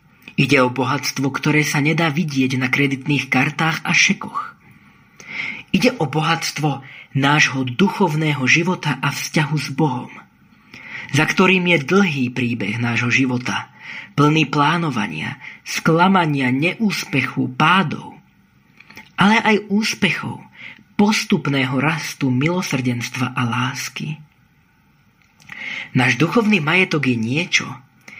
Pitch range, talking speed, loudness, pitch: 130-175 Hz, 100 wpm, -18 LUFS, 150 Hz